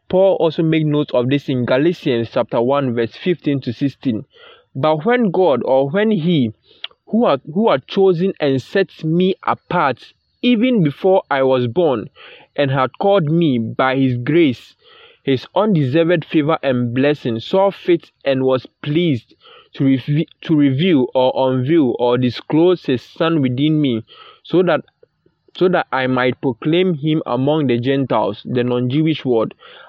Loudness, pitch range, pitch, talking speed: -17 LUFS, 130-180 Hz, 150 Hz, 155 wpm